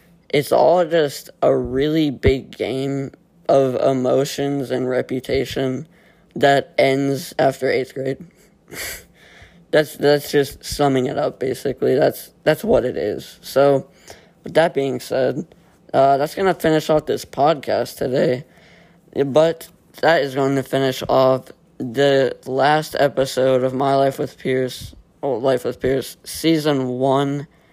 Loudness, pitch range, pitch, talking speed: -19 LUFS, 130-155 Hz, 140 Hz, 140 wpm